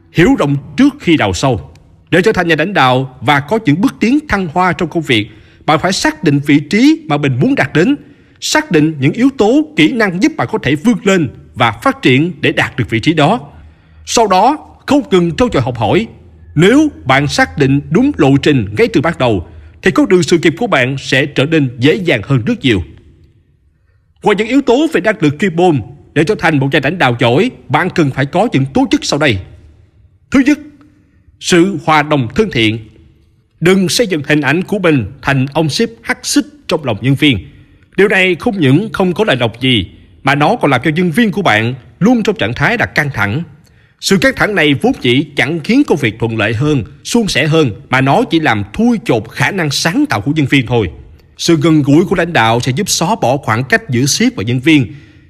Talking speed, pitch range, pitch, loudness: 230 wpm, 125-190 Hz, 150 Hz, -12 LUFS